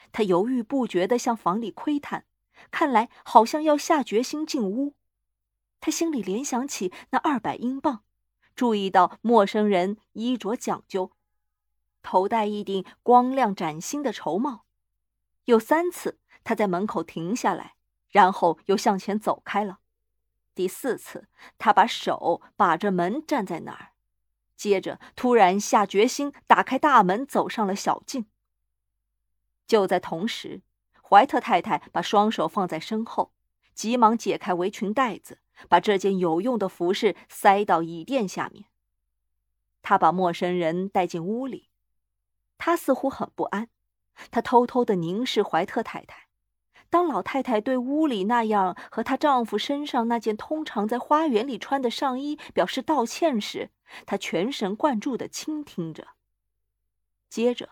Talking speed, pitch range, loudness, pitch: 215 characters per minute, 180-255 Hz, -24 LUFS, 215 Hz